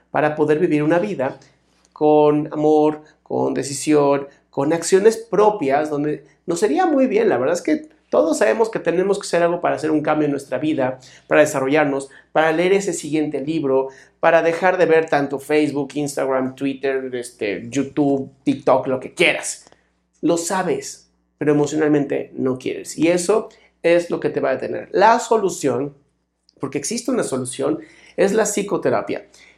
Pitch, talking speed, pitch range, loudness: 150 Hz, 160 wpm, 135-170 Hz, -19 LUFS